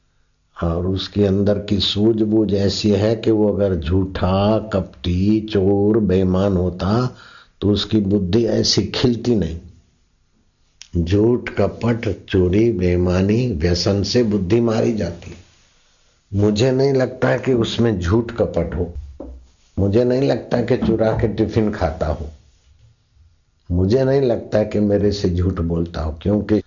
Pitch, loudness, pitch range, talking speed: 100 Hz, -18 LUFS, 90-110 Hz, 135 wpm